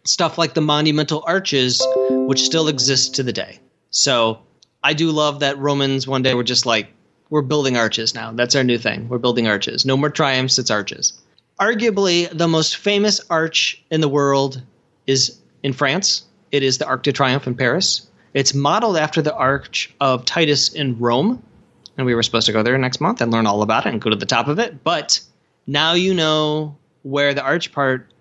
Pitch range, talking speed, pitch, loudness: 125-155 Hz, 200 wpm, 140 Hz, -18 LUFS